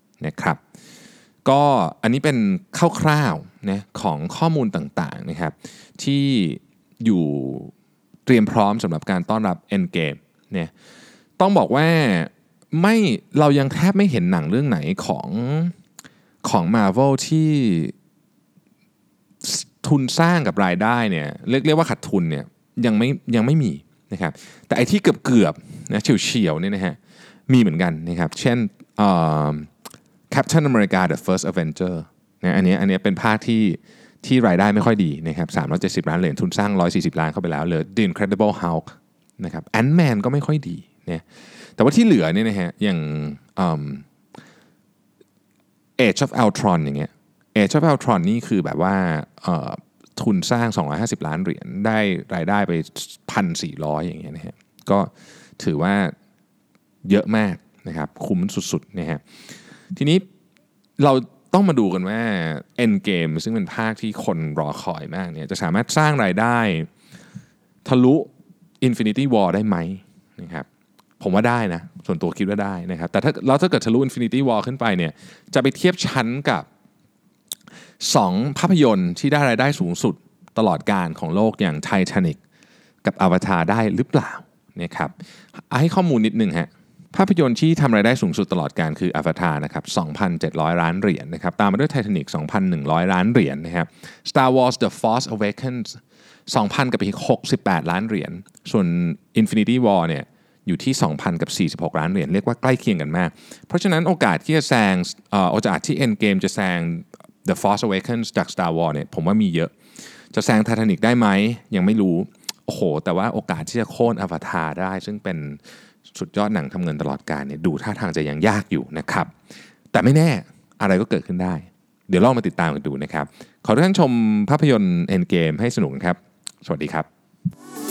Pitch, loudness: 120 Hz, -20 LUFS